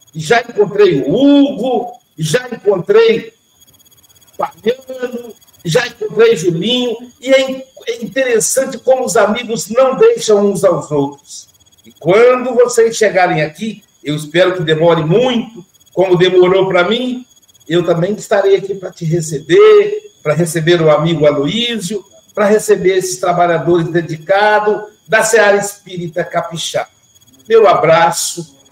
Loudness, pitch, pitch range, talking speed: -12 LUFS, 205 Hz, 170-235 Hz, 125 wpm